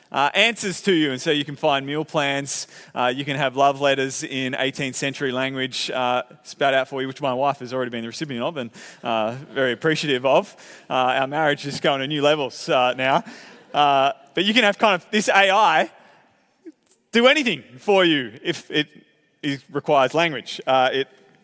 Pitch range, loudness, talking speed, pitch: 130-160 Hz, -21 LUFS, 200 wpm, 140 Hz